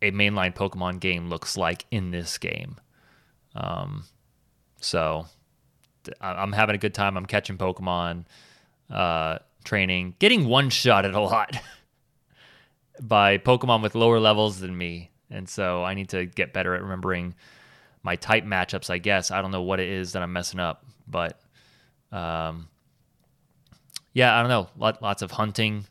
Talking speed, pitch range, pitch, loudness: 150 wpm, 90-110 Hz, 95 Hz, -24 LUFS